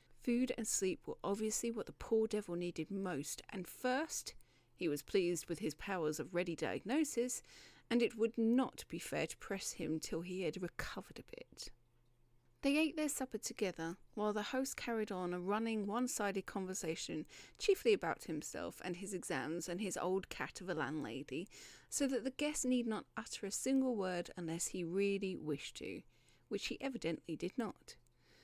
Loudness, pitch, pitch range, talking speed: -40 LUFS, 200 Hz, 175-240 Hz, 180 wpm